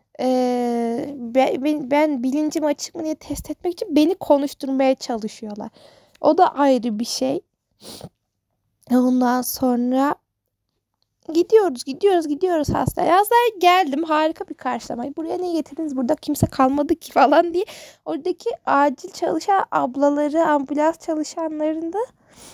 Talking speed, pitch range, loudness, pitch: 125 wpm, 265-335 Hz, -20 LUFS, 300 Hz